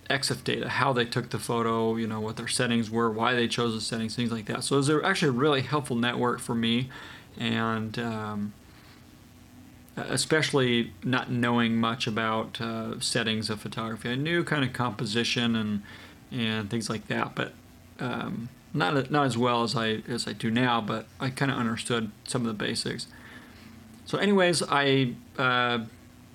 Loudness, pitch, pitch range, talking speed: -27 LUFS, 120 Hz, 115-125 Hz, 175 wpm